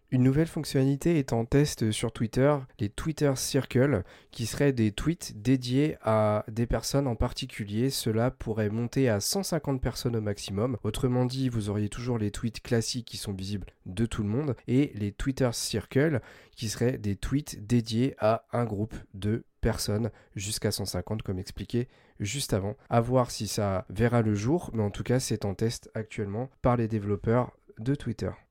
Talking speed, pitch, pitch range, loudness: 175 wpm, 115 Hz, 105-130 Hz, -29 LUFS